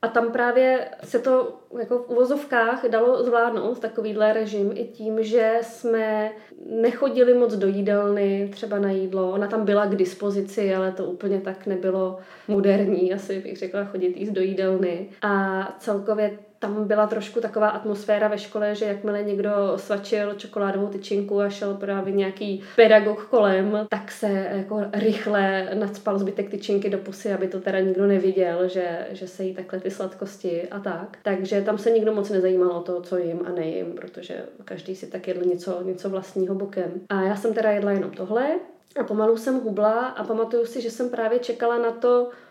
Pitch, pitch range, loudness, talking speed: 205 Hz, 195-225 Hz, -24 LUFS, 180 wpm